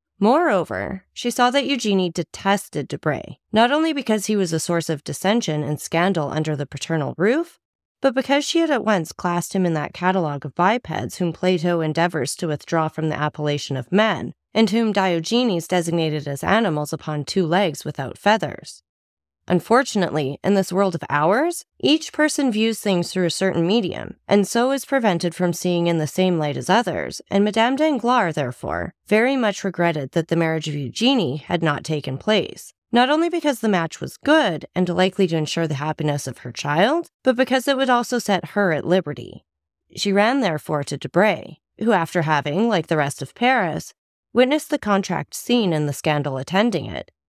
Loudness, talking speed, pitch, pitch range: -21 LUFS, 185 wpm, 180 Hz, 155-225 Hz